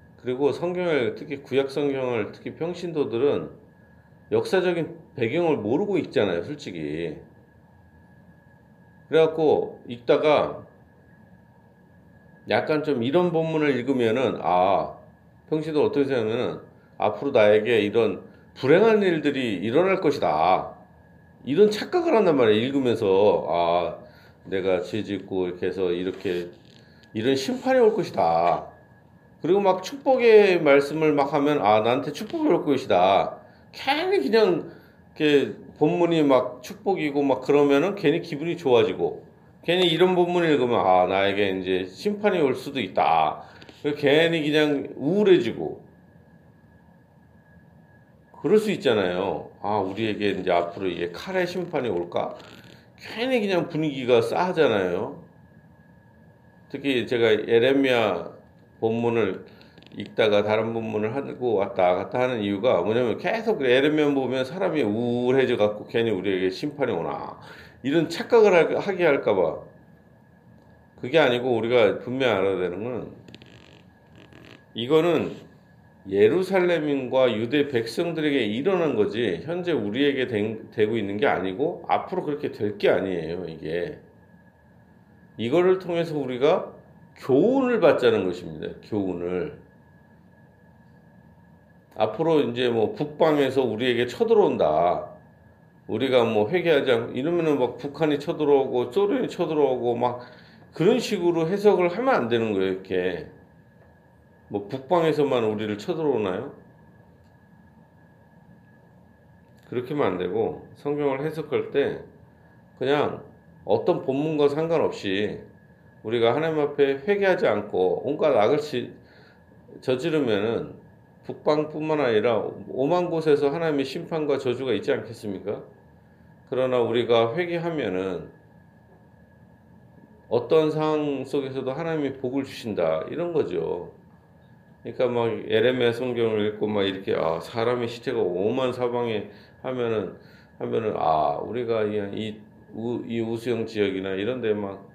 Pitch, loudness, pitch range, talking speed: 145 Hz, -23 LUFS, 115-175 Hz, 270 characters per minute